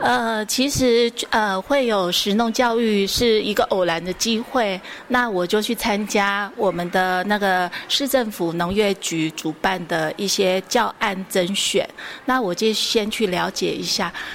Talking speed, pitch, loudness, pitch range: 220 characters per minute, 210 Hz, -20 LUFS, 185-230 Hz